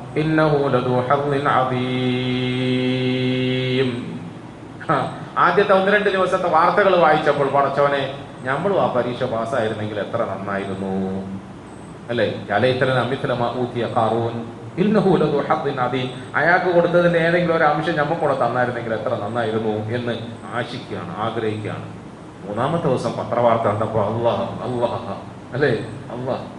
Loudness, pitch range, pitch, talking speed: -20 LUFS, 115-145 Hz, 125 Hz, 75 wpm